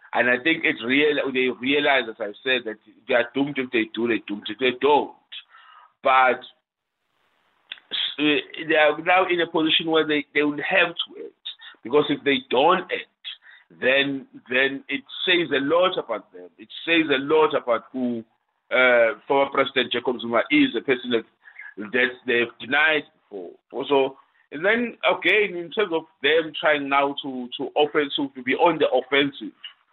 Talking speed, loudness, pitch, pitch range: 175 wpm, -22 LUFS, 140 Hz, 130-160 Hz